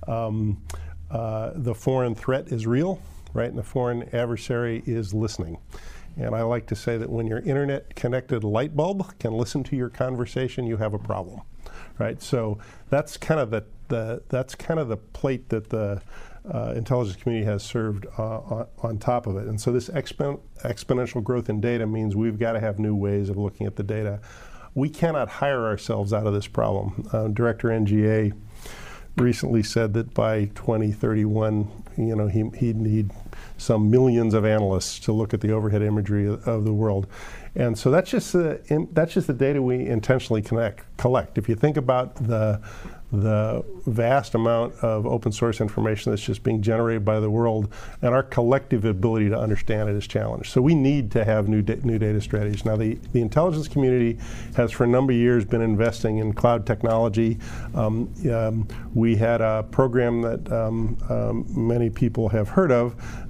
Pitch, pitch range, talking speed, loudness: 115 Hz, 110-125 Hz, 185 wpm, -24 LUFS